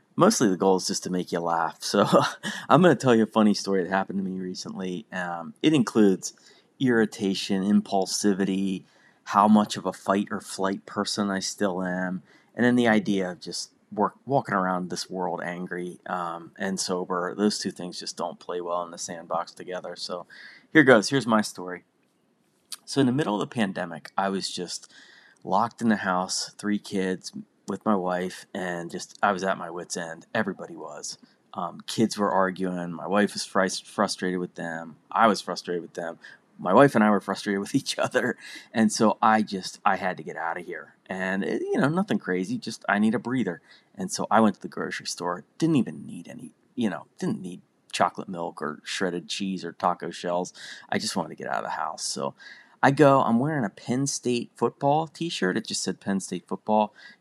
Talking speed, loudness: 205 wpm, -26 LUFS